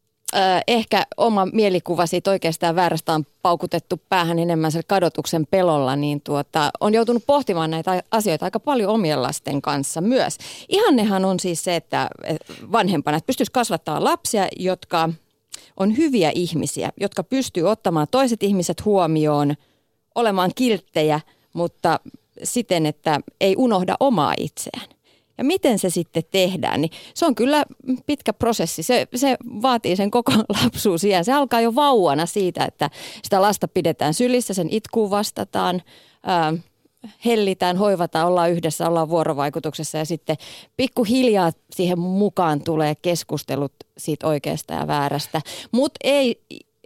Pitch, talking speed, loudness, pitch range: 180 Hz, 135 wpm, -21 LUFS, 160-225 Hz